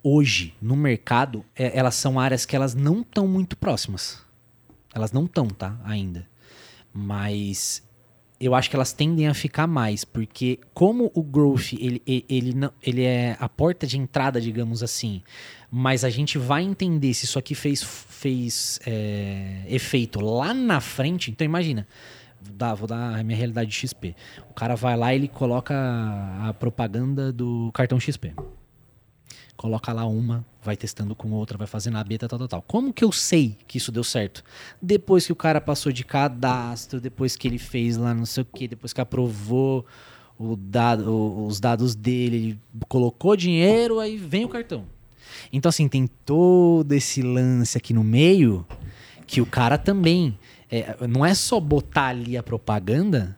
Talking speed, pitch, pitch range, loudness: 170 wpm, 125 Hz, 115-140 Hz, -23 LUFS